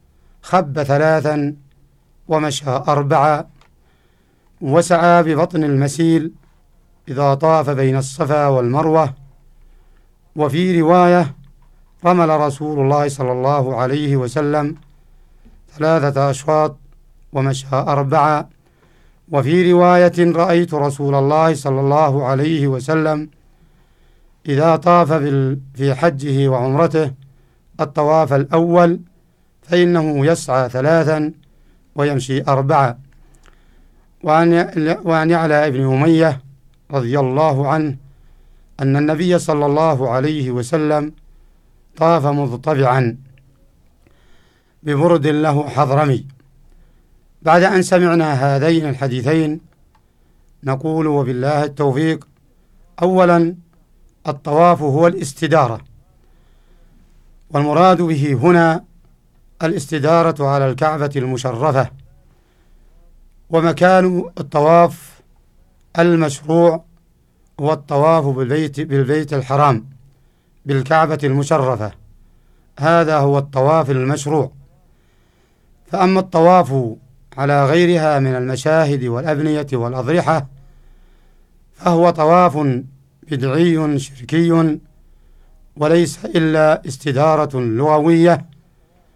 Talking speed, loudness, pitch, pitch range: 75 wpm, -15 LUFS, 145 Hz, 135-160 Hz